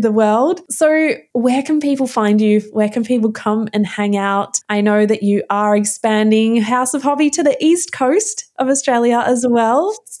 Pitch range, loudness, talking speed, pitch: 210-285 Hz, -15 LUFS, 195 wpm, 235 Hz